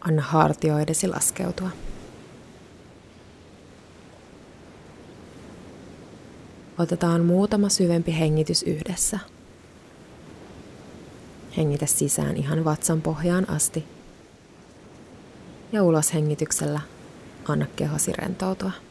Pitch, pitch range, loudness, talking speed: 160 Hz, 150-180 Hz, -23 LUFS, 65 wpm